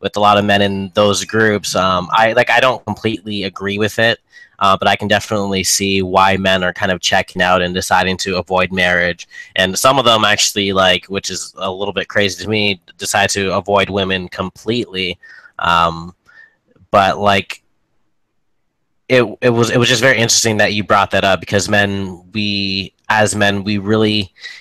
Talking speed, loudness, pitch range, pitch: 190 wpm, -14 LUFS, 95-105 Hz, 100 Hz